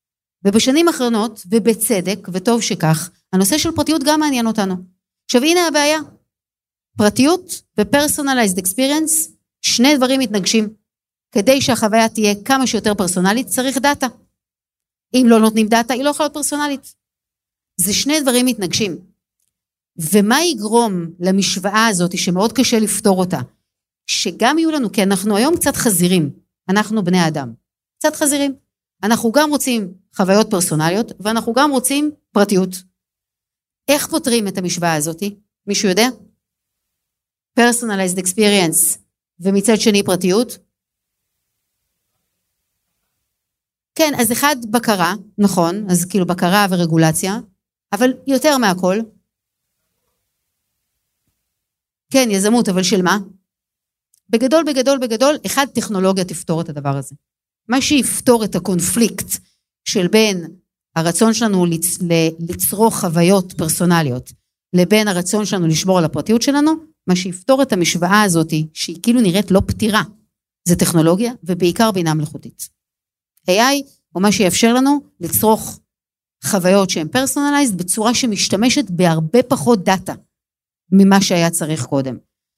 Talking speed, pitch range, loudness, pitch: 115 wpm, 180-250 Hz, -16 LUFS, 210 Hz